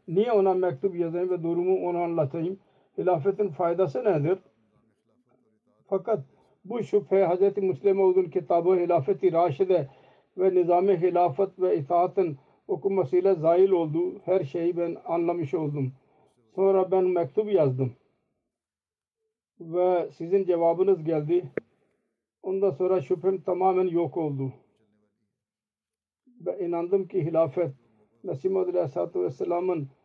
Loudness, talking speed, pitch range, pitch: -26 LUFS, 110 wpm, 165-190 Hz, 180 Hz